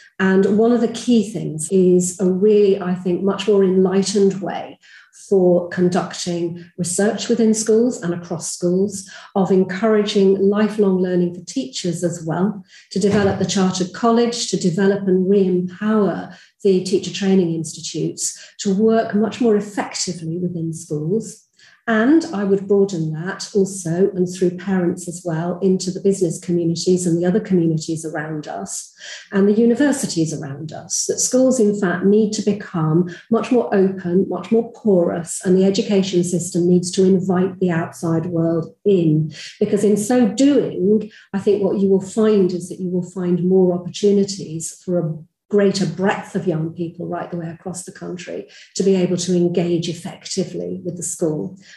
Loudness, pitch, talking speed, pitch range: -18 LUFS, 190 Hz, 165 wpm, 175-205 Hz